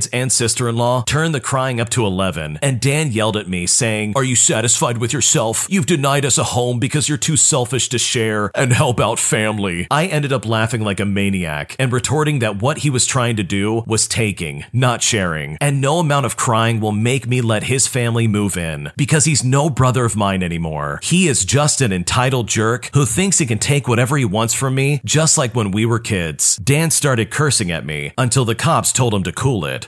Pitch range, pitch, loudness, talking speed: 105-140 Hz, 120 Hz, -16 LUFS, 225 wpm